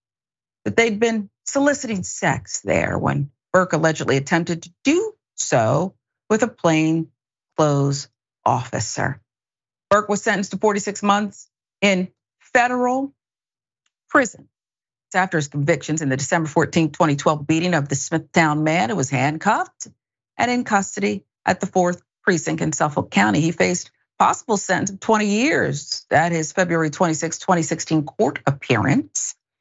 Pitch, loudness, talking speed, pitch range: 170 Hz, -20 LUFS, 140 wpm, 150-205 Hz